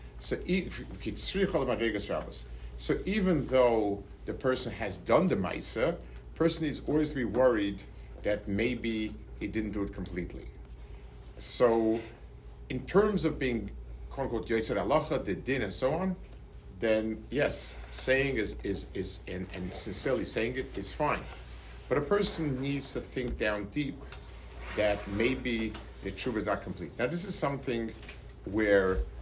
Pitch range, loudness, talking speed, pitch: 95-135 Hz, -31 LUFS, 140 wpm, 110 Hz